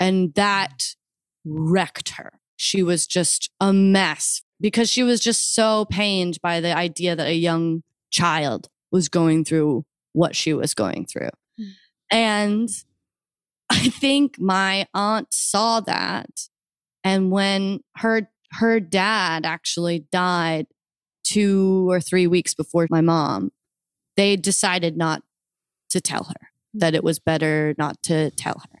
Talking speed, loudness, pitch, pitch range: 135 wpm, -21 LUFS, 180 Hz, 165-200 Hz